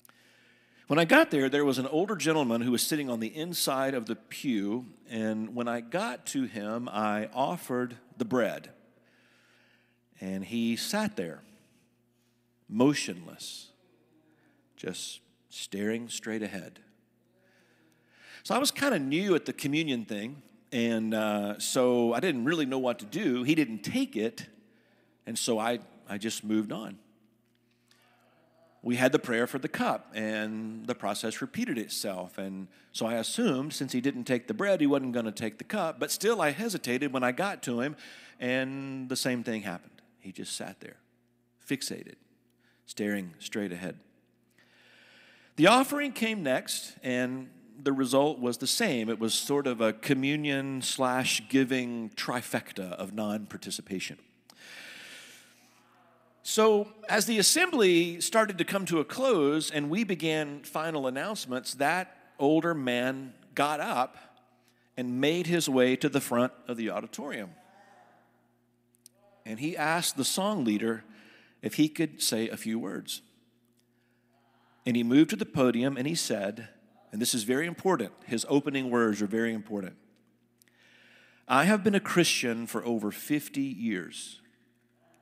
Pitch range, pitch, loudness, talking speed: 115-155 Hz, 125 Hz, -29 LUFS, 150 wpm